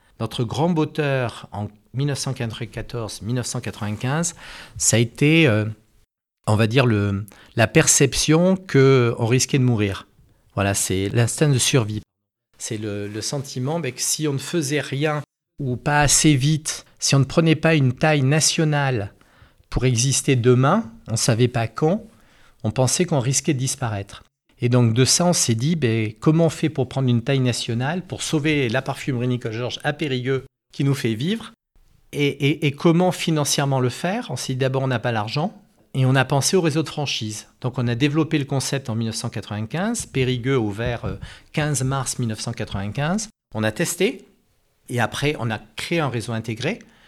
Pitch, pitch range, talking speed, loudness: 130 Hz, 115-150 Hz, 175 wpm, -21 LUFS